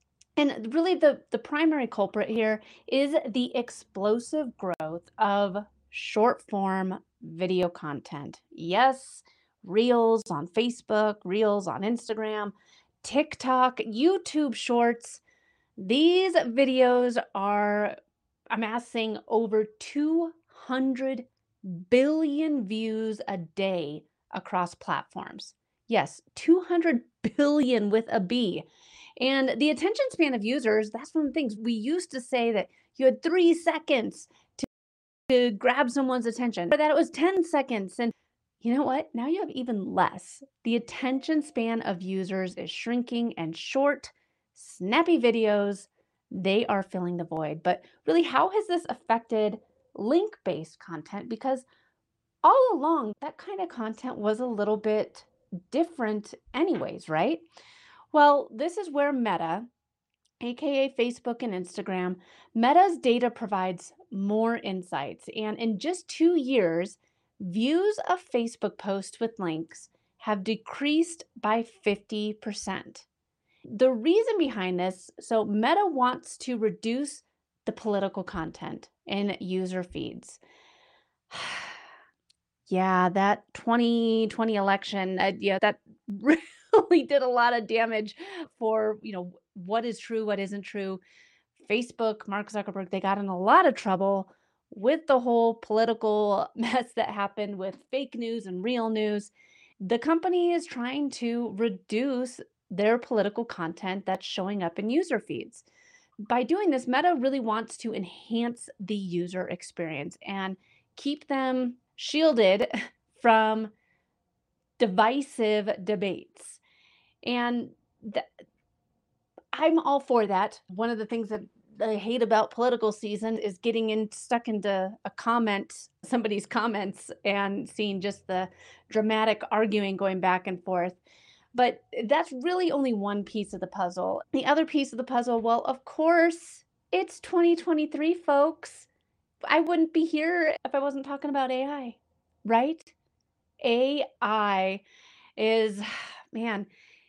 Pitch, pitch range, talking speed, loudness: 230 Hz, 205-275 Hz, 130 wpm, -27 LUFS